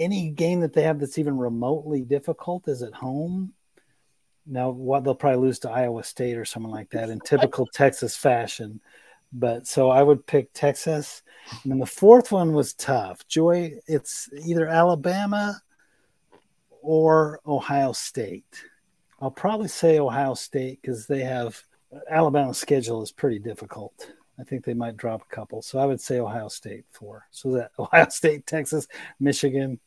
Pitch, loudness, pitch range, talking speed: 140 Hz, -23 LUFS, 125-160 Hz, 160 wpm